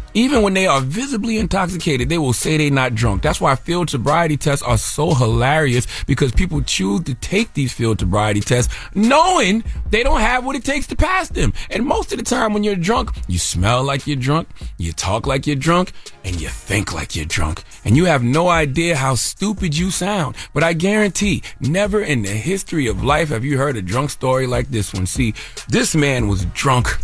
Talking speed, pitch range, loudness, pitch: 210 wpm, 115-185 Hz, -18 LUFS, 140 Hz